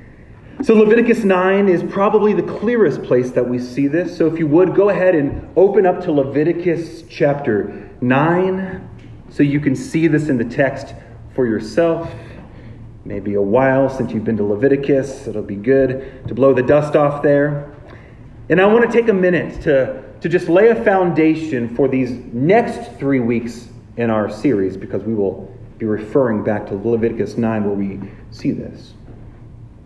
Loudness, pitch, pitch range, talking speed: -16 LUFS, 135 Hz, 115-165 Hz, 175 wpm